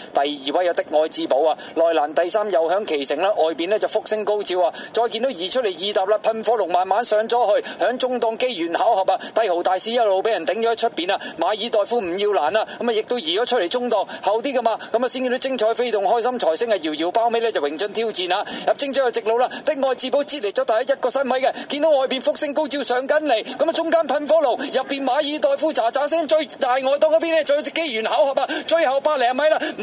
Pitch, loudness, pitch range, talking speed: 245 Hz, -17 LUFS, 215-290 Hz, 360 characters per minute